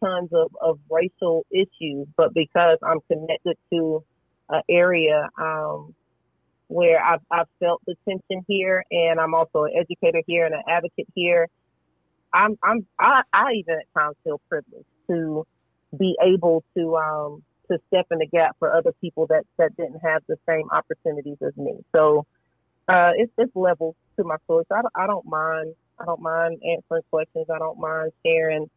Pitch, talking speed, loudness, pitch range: 165 Hz, 170 wpm, -22 LUFS, 155-175 Hz